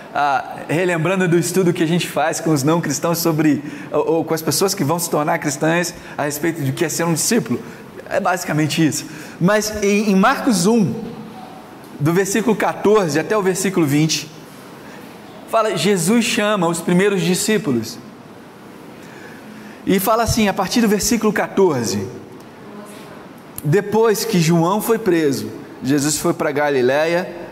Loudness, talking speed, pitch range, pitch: -17 LUFS, 145 wpm, 155-205 Hz, 170 Hz